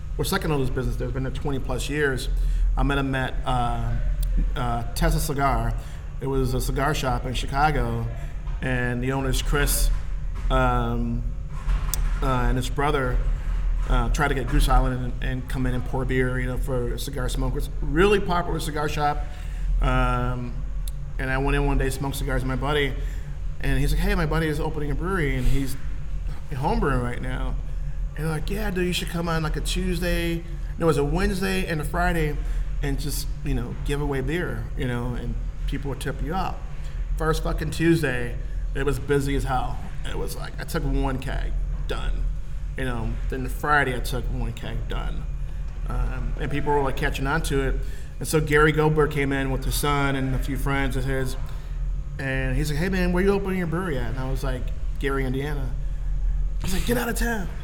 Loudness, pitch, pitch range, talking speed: -26 LUFS, 130 Hz, 120-145 Hz, 200 wpm